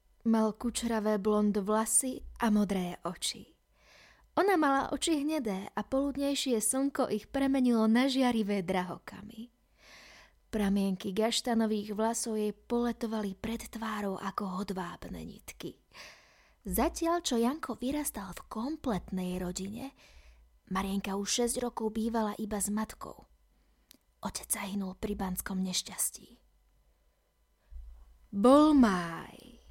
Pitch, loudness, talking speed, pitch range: 220 Hz, -31 LUFS, 105 wpm, 195-245 Hz